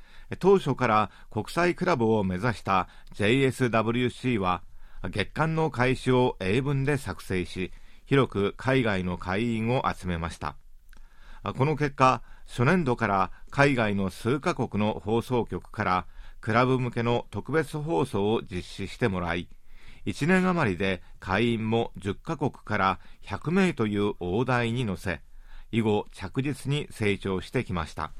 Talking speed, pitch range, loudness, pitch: 245 characters per minute, 95-130 Hz, -27 LUFS, 110 Hz